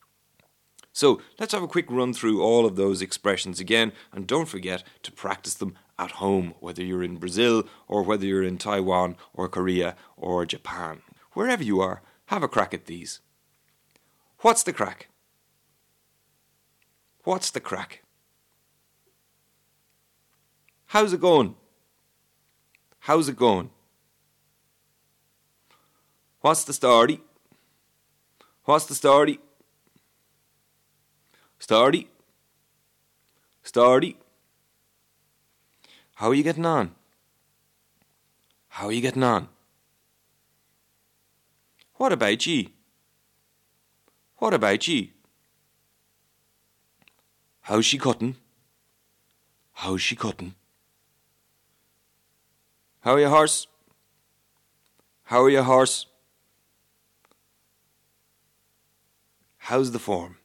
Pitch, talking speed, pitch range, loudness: 115 Hz, 95 wpm, 95-140 Hz, -23 LUFS